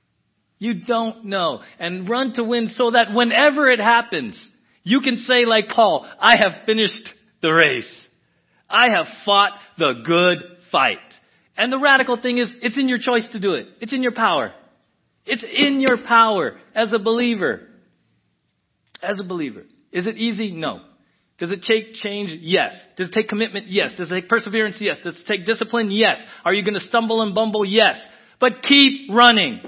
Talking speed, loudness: 180 wpm, -18 LUFS